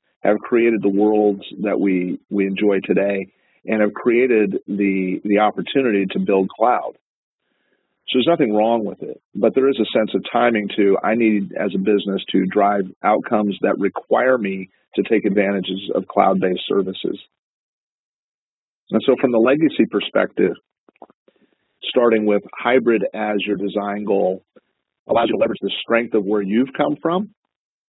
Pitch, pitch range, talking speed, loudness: 105 Hz, 100-115 Hz, 155 wpm, -19 LUFS